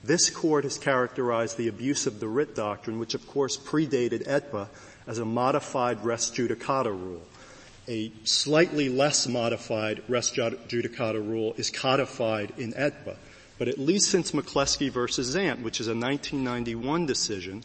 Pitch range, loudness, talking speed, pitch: 115-140 Hz, -27 LUFS, 150 wpm, 120 Hz